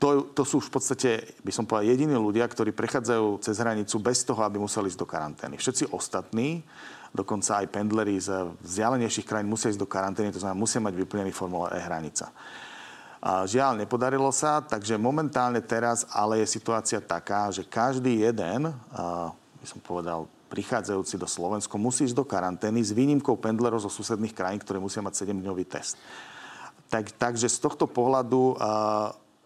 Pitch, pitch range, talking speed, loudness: 110 Hz, 100-120 Hz, 170 wpm, -28 LUFS